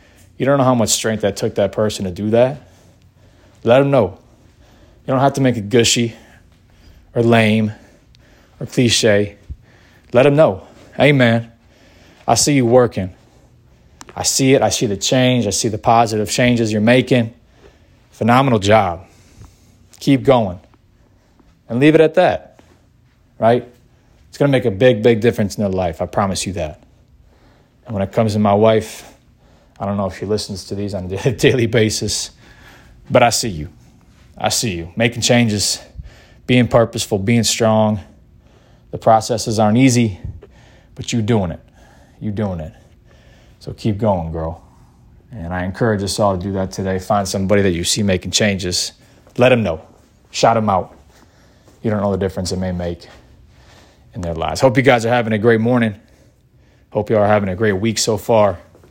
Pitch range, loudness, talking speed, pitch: 95-120 Hz, -16 LUFS, 175 wpm, 110 Hz